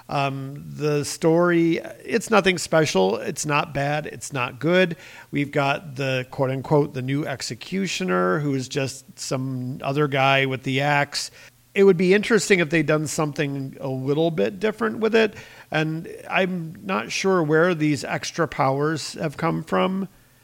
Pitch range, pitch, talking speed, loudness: 135-175 Hz, 150 Hz, 160 wpm, -22 LUFS